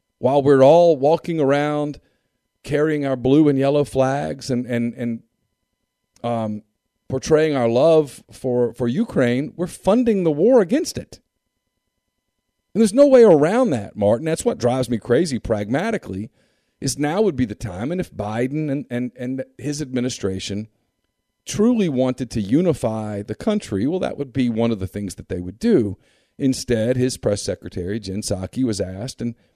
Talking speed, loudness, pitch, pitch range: 165 wpm, -20 LUFS, 125 Hz, 110-150 Hz